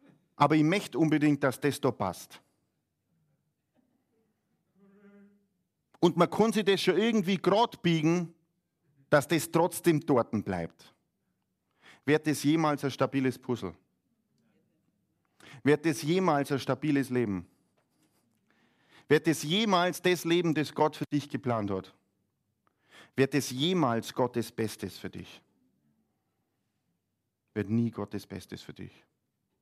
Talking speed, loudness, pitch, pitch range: 120 wpm, -28 LUFS, 145 Hz, 115-170 Hz